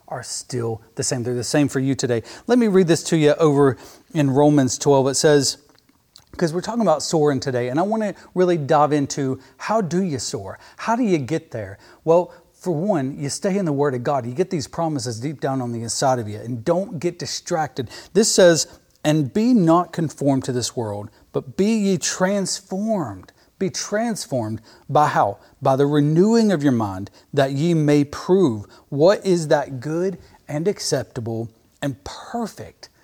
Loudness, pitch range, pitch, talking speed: -20 LUFS, 130-180 Hz, 150 Hz, 190 wpm